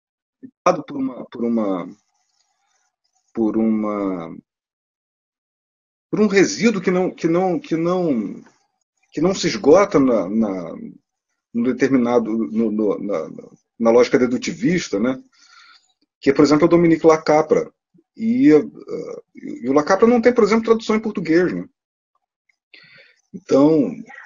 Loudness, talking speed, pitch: -18 LUFS, 125 wpm, 215 Hz